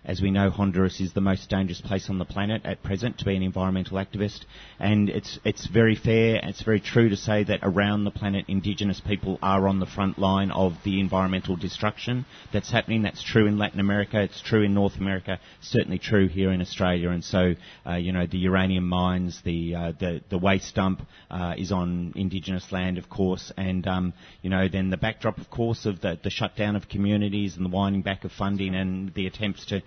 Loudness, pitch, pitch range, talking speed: -26 LUFS, 95 Hz, 95-100 Hz, 215 wpm